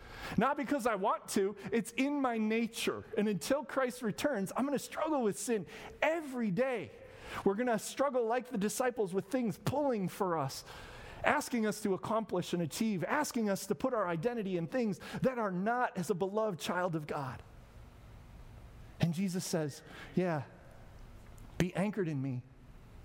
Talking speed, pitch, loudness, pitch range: 165 wpm, 210 Hz, -35 LUFS, 175-245 Hz